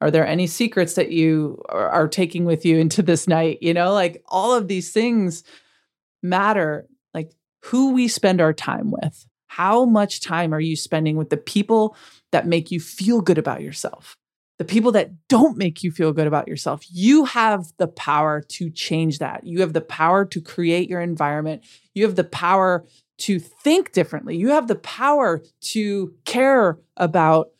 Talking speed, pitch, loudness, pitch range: 180 wpm, 175 Hz, -20 LUFS, 160-210 Hz